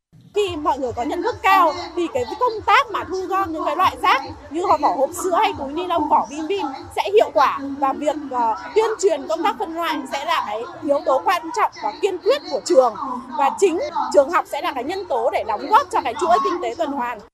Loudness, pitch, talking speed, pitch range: -20 LUFS, 335 Hz, 250 wpm, 285-395 Hz